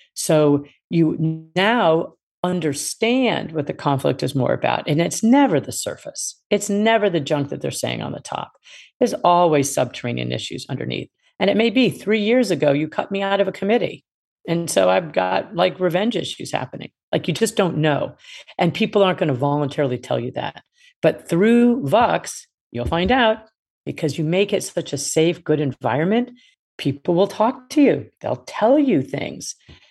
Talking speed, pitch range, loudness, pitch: 180 wpm, 150-225 Hz, -20 LUFS, 180 Hz